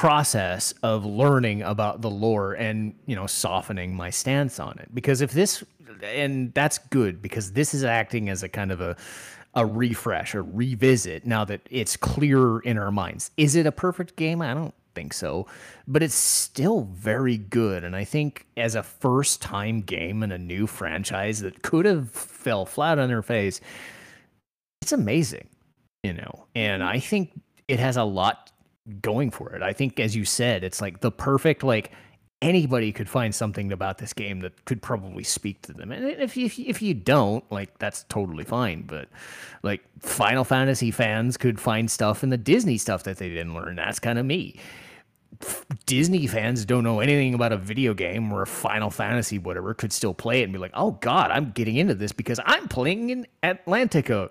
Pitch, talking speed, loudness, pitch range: 115 Hz, 190 wpm, -25 LUFS, 105-135 Hz